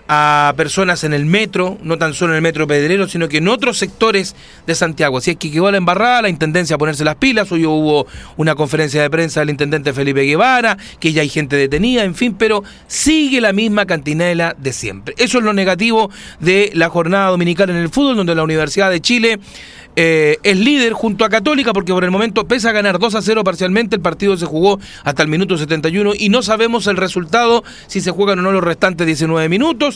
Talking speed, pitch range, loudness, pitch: 220 wpm, 160-220 Hz, -14 LUFS, 185 Hz